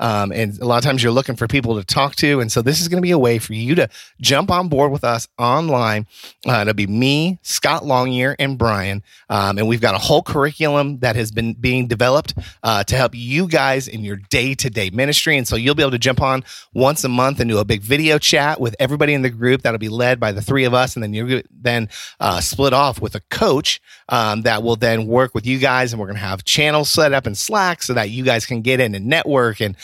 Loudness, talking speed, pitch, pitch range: -17 LUFS, 265 wpm, 125 Hz, 115-140 Hz